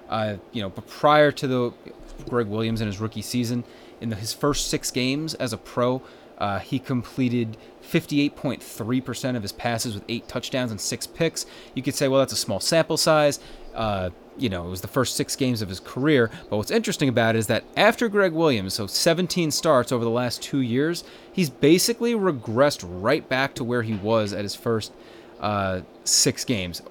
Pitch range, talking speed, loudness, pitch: 110-145 Hz, 195 wpm, -24 LUFS, 125 Hz